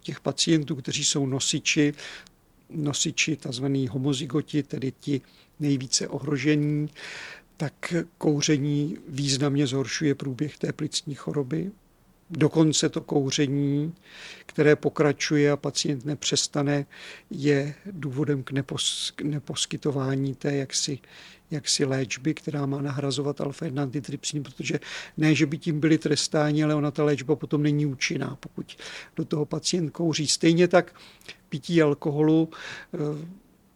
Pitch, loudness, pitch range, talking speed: 150 Hz, -26 LUFS, 140-155 Hz, 115 wpm